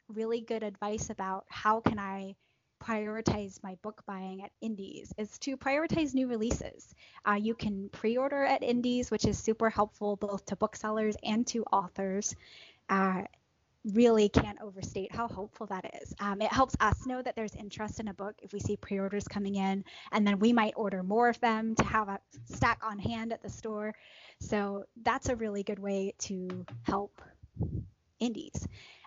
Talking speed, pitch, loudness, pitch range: 175 wpm, 215 Hz, -33 LUFS, 200-225 Hz